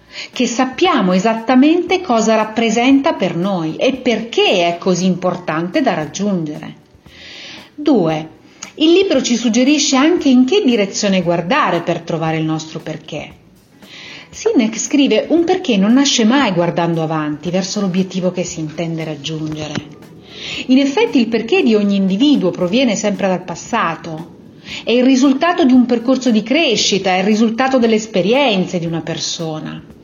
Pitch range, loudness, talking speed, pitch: 170-265 Hz, -15 LUFS, 140 wpm, 215 Hz